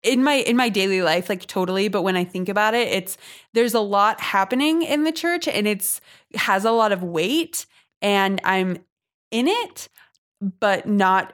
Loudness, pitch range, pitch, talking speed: -21 LUFS, 190-255 Hz, 205 Hz, 190 wpm